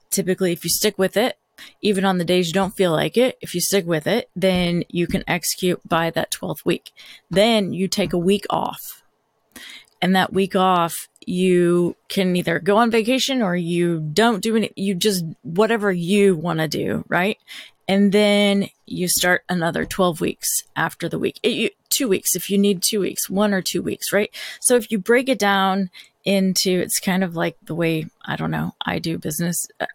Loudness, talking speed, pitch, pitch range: -20 LUFS, 200 wpm, 190 Hz, 175-205 Hz